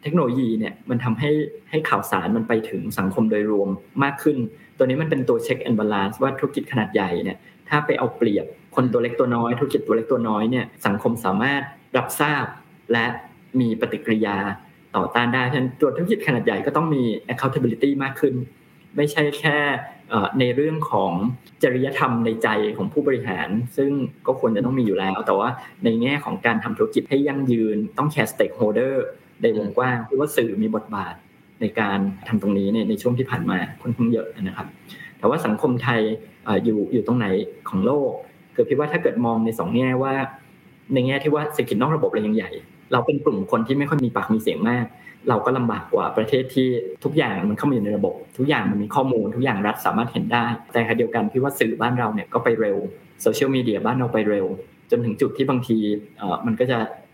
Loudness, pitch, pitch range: -22 LUFS, 125 Hz, 110-140 Hz